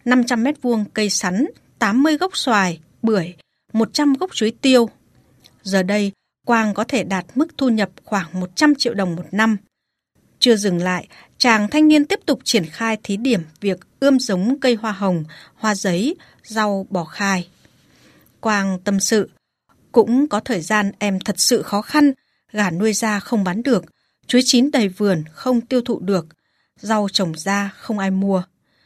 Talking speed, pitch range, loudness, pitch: 175 wpm, 195-250 Hz, -19 LUFS, 215 Hz